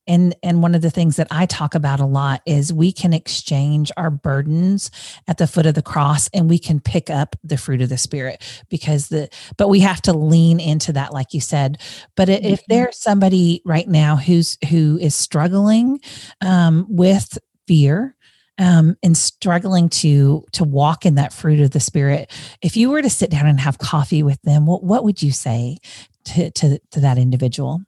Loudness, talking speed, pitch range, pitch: -16 LUFS, 200 wpm, 145-175 Hz, 160 Hz